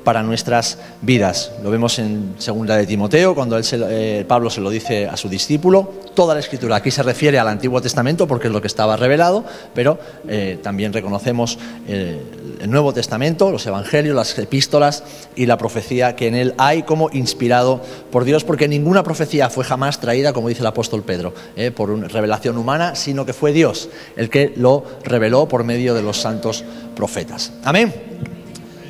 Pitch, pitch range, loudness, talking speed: 120 Hz, 110-140 Hz, -17 LUFS, 185 wpm